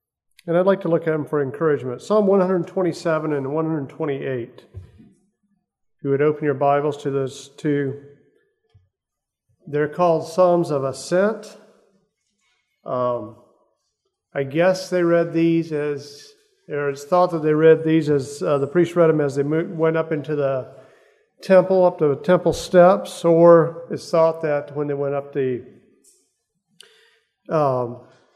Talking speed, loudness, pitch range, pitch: 145 wpm, -20 LUFS, 140-180 Hz, 160 Hz